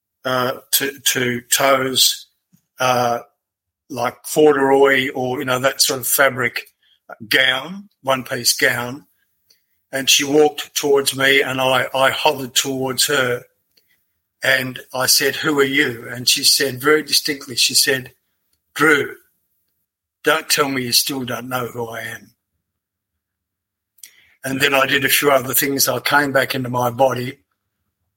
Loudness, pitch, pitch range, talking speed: -16 LUFS, 130 Hz, 120-140 Hz, 145 wpm